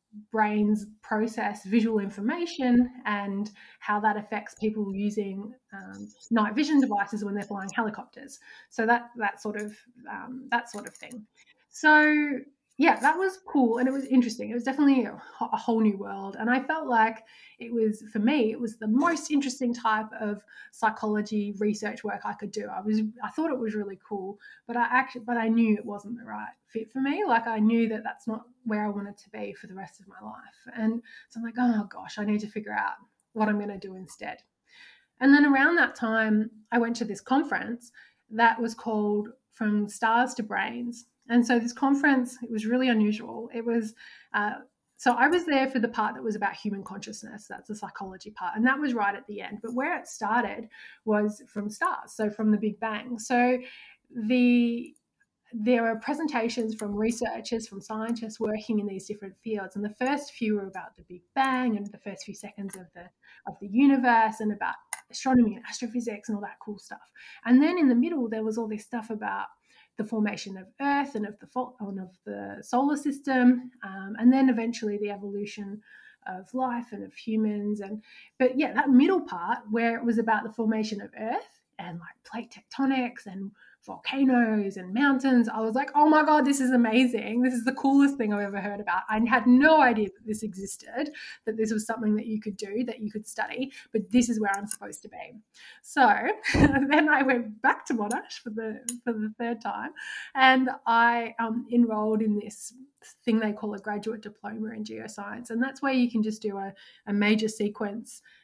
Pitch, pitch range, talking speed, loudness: 225 Hz, 210-250 Hz, 205 wpm, -27 LUFS